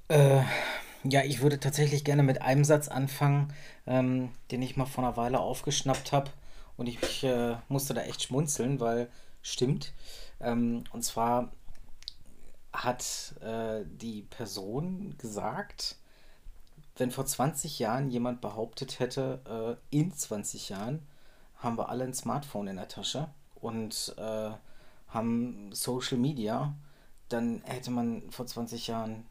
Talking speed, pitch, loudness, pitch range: 135 wpm, 125 Hz, -32 LUFS, 115-140 Hz